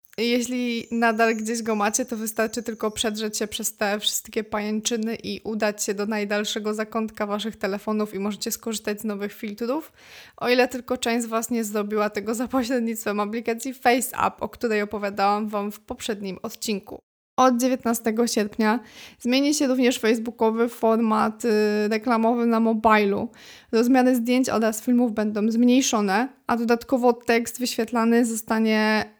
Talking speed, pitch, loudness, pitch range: 145 wpm, 225 Hz, -23 LUFS, 215-240 Hz